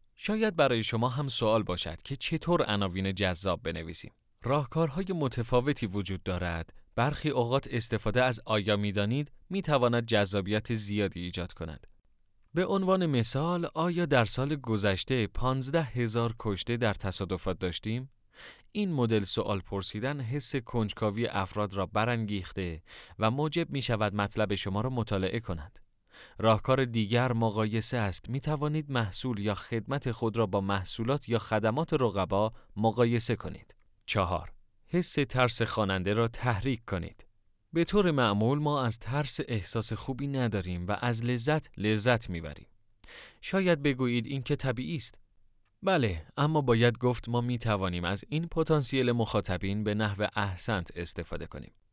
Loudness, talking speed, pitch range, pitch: -30 LUFS, 135 wpm, 100-135 Hz, 115 Hz